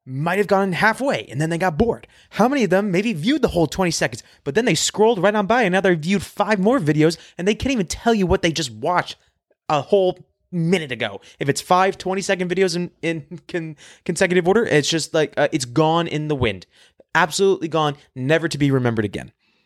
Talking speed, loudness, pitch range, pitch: 225 wpm, -20 LUFS, 155-195 Hz, 175 Hz